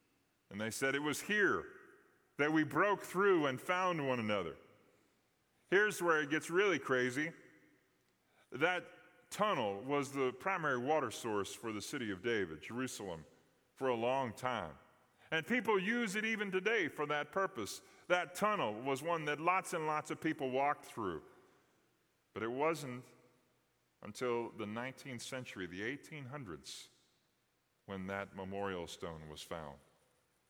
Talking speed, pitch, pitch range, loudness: 145 wpm, 145 Hz, 125-185 Hz, -37 LUFS